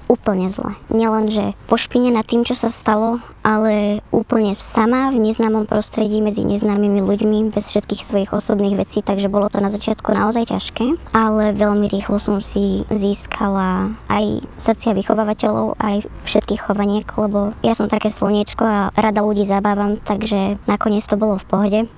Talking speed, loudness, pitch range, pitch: 155 wpm, -17 LUFS, 205-220 Hz, 210 Hz